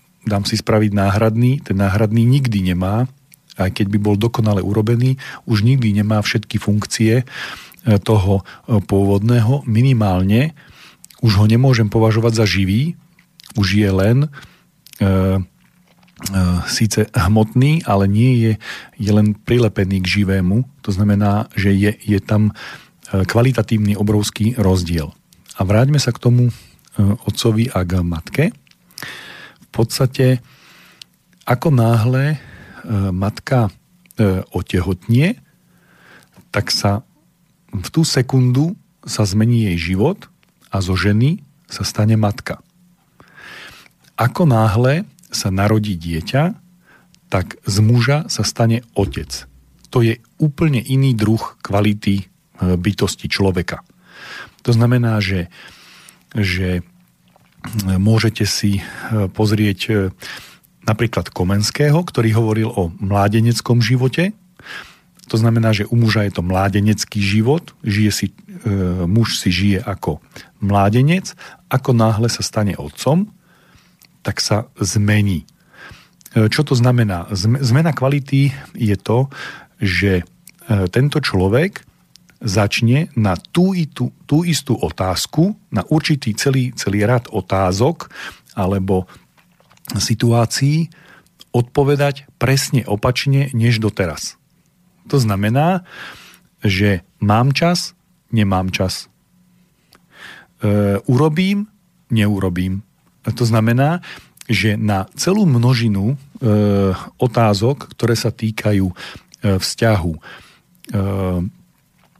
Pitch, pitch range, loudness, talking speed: 110 Hz, 100-135 Hz, -17 LUFS, 105 wpm